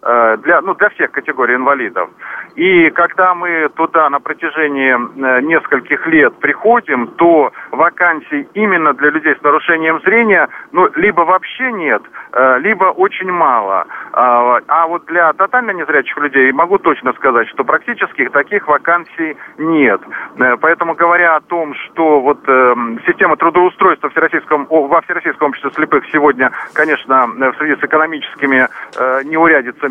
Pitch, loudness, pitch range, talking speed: 155 Hz, -12 LUFS, 140-175 Hz, 130 wpm